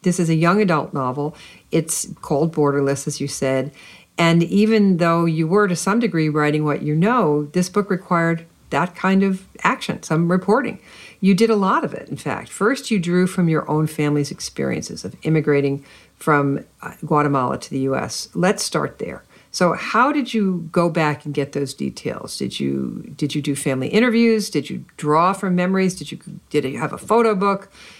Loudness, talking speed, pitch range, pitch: -20 LUFS, 190 wpm, 150-195 Hz, 165 Hz